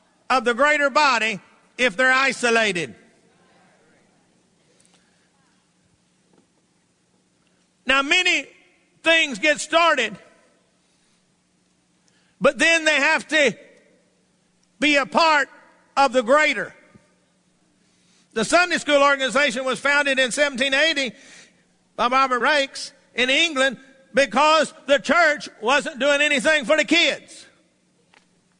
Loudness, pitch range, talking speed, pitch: -19 LUFS, 260-305 Hz, 95 wpm, 280 Hz